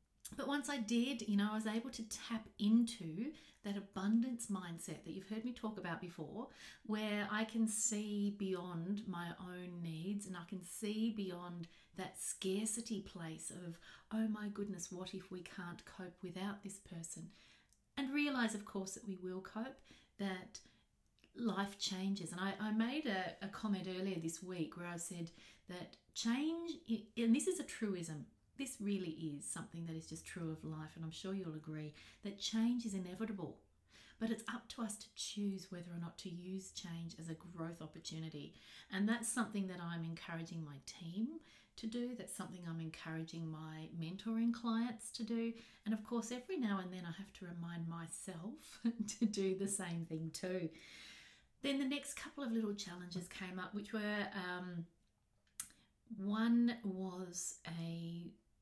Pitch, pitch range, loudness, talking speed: 195 Hz, 170-220 Hz, -43 LUFS, 175 wpm